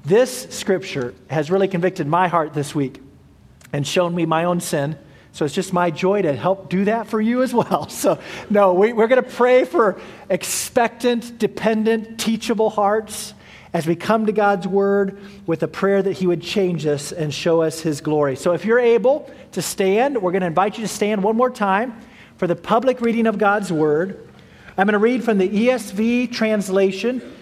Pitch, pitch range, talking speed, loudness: 195 Hz, 175-225 Hz, 195 wpm, -19 LUFS